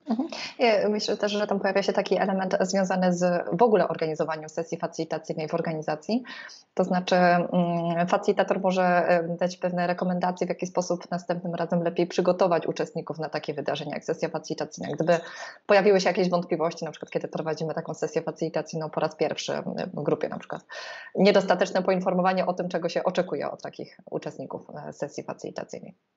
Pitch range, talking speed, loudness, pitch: 165-190 Hz, 160 wpm, -26 LUFS, 175 Hz